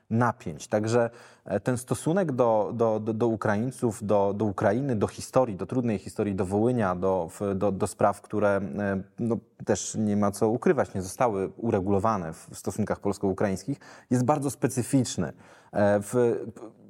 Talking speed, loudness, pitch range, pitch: 145 wpm, -27 LUFS, 100-120 Hz, 110 Hz